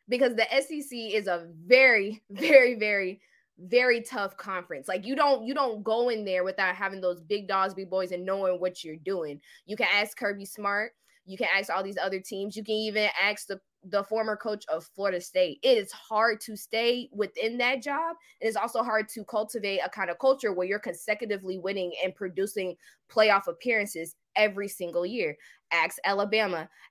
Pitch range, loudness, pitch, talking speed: 190-225 Hz, -27 LUFS, 205 Hz, 190 wpm